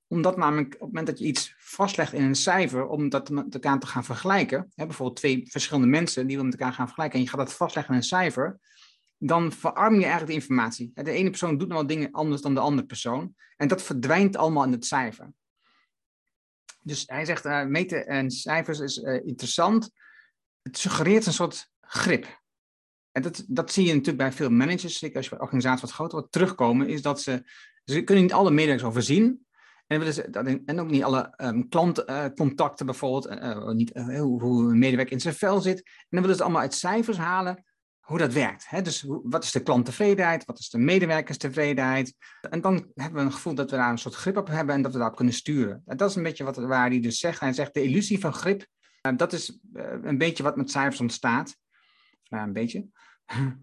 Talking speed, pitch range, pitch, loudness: 210 wpm, 130-175 Hz, 145 Hz, -26 LUFS